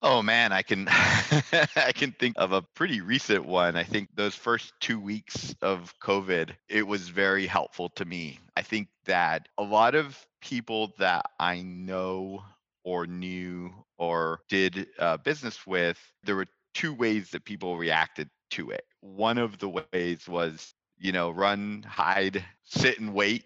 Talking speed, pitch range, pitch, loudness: 165 wpm, 90-110 Hz, 95 Hz, -28 LUFS